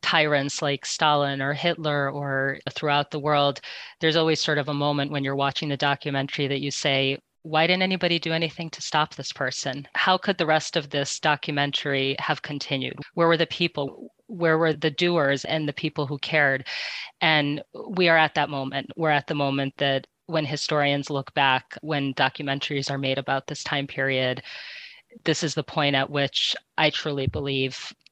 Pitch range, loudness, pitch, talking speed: 140-160 Hz, -24 LUFS, 145 Hz, 185 wpm